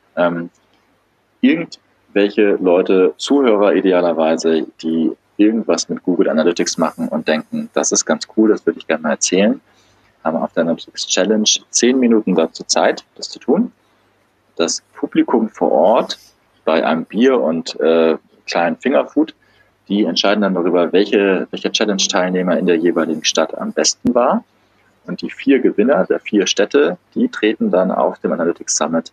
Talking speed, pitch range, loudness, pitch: 155 wpm, 80-110 Hz, -16 LUFS, 90 Hz